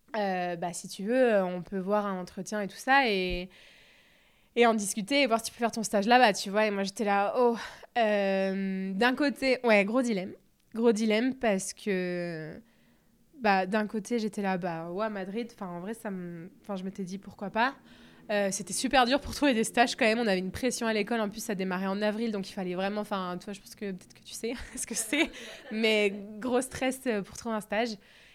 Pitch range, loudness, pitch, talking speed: 195-235 Hz, -29 LUFS, 210 Hz, 225 wpm